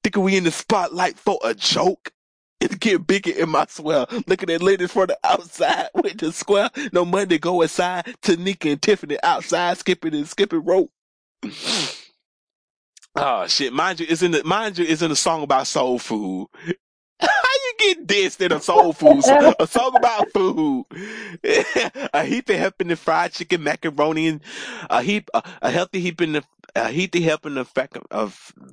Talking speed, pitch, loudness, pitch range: 185 wpm, 180 Hz, -20 LUFS, 165-245 Hz